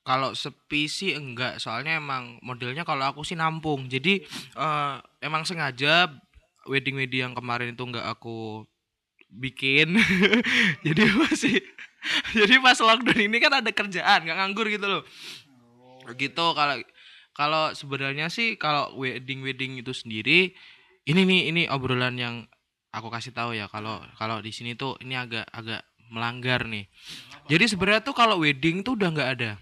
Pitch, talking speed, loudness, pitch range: 140 Hz, 150 wpm, -24 LUFS, 120-180 Hz